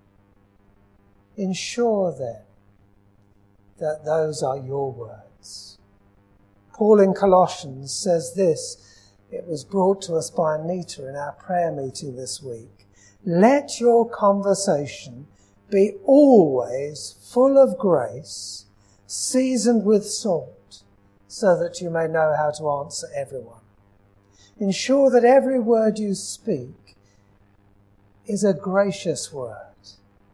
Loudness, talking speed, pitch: -21 LUFS, 110 wpm, 140 Hz